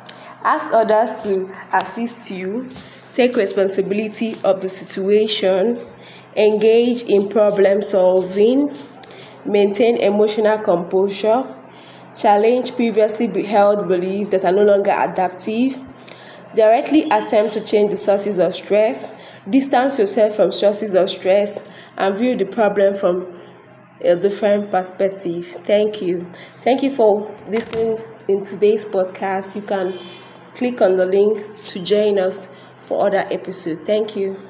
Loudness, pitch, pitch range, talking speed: -17 LUFS, 205 Hz, 195-220 Hz, 125 wpm